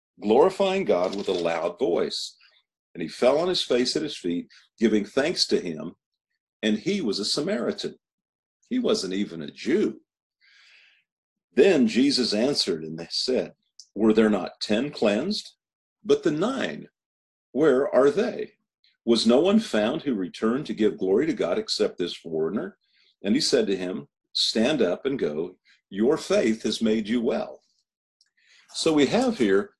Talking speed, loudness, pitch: 160 wpm, -24 LUFS, 110 Hz